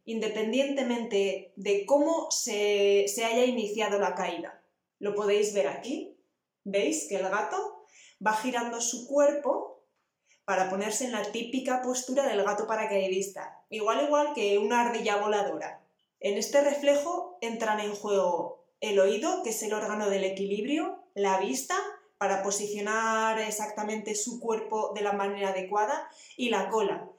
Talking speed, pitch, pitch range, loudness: 140 wpm, 215 Hz, 200-260 Hz, -29 LUFS